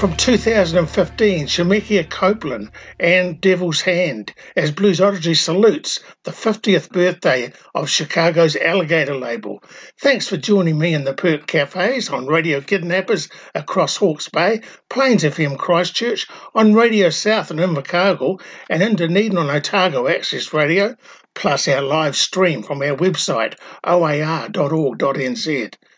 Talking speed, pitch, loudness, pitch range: 130 wpm, 180 Hz, -17 LUFS, 155-200 Hz